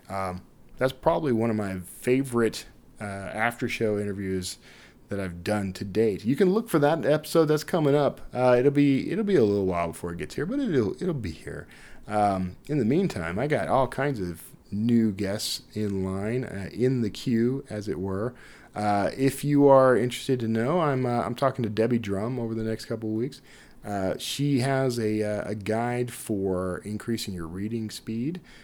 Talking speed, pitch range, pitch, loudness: 195 wpm, 100-130 Hz, 115 Hz, -26 LUFS